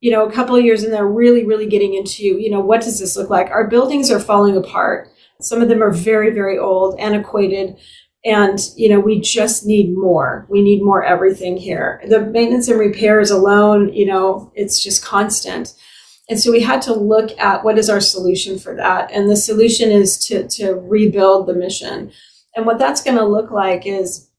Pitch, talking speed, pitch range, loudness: 205 Hz, 210 wpm, 195-220 Hz, -14 LUFS